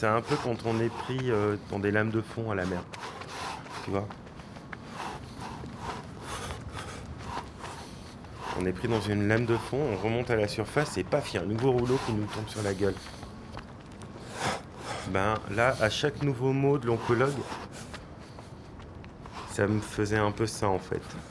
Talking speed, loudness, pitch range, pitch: 170 wpm, -30 LUFS, 105-125 Hz, 110 Hz